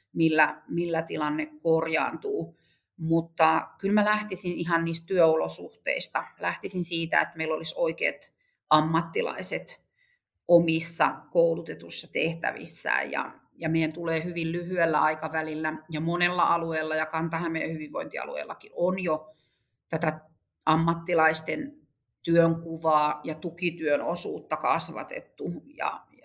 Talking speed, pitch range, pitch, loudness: 100 wpm, 155-175 Hz, 165 Hz, -27 LUFS